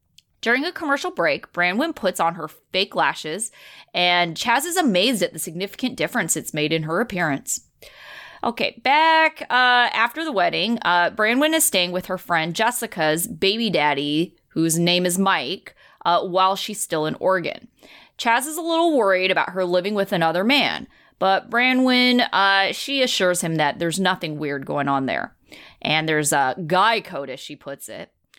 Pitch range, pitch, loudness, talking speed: 165-240 Hz, 185 Hz, -20 LUFS, 175 wpm